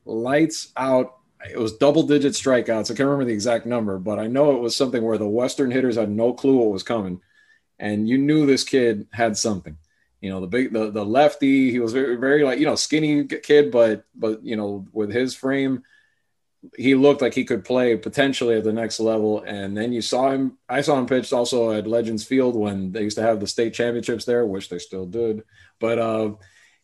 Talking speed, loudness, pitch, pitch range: 220 wpm, -21 LUFS, 120 Hz, 110-135 Hz